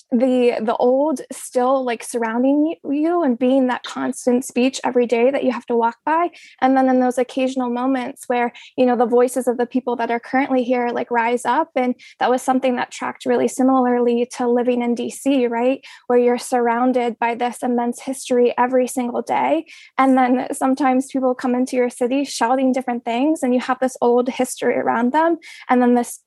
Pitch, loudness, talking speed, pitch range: 255 Hz, -19 LUFS, 195 wpm, 245-265 Hz